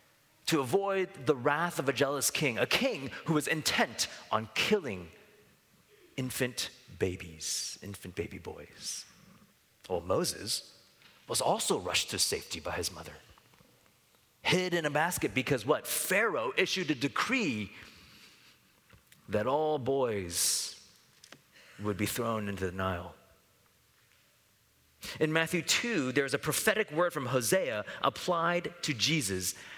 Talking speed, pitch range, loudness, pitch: 125 wpm, 105-160 Hz, -31 LUFS, 140 Hz